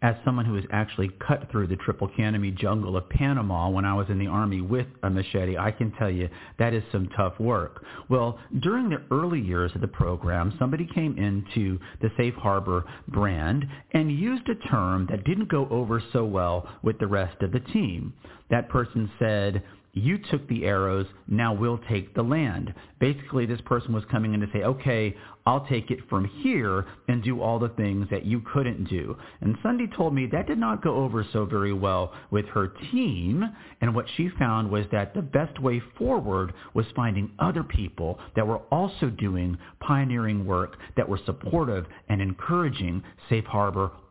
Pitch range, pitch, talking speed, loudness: 100-130 Hz, 110 Hz, 190 wpm, -27 LUFS